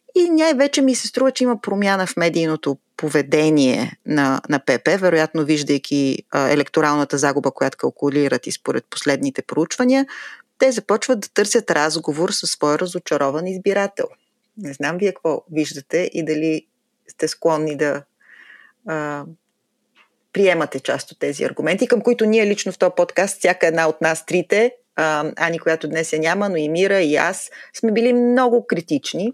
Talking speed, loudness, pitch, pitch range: 160 wpm, -19 LUFS, 165 Hz, 150-210 Hz